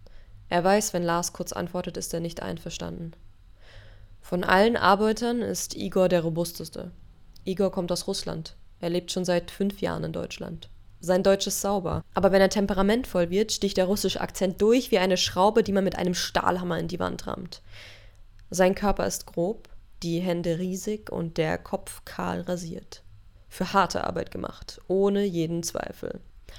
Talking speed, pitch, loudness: 165 wpm, 180 Hz, -26 LUFS